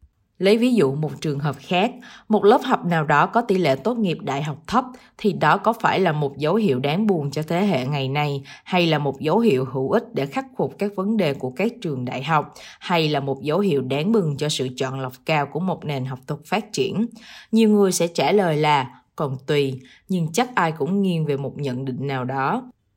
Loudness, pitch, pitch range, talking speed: -22 LUFS, 155 Hz, 140-205 Hz, 240 wpm